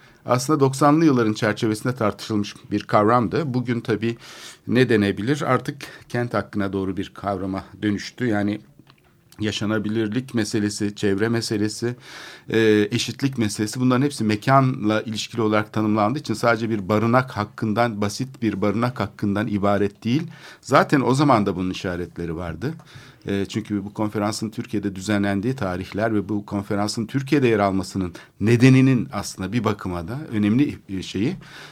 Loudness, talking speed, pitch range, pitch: -22 LUFS, 130 wpm, 105-120 Hz, 110 Hz